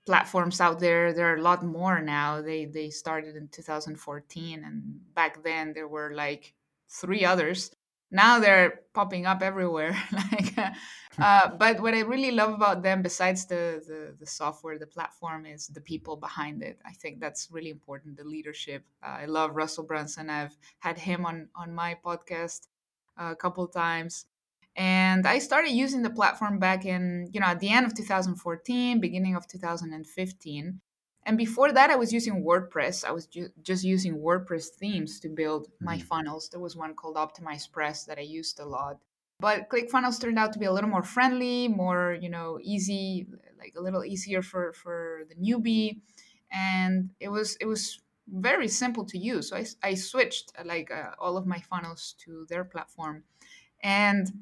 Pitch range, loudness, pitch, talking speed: 160-200 Hz, -27 LUFS, 175 Hz, 180 wpm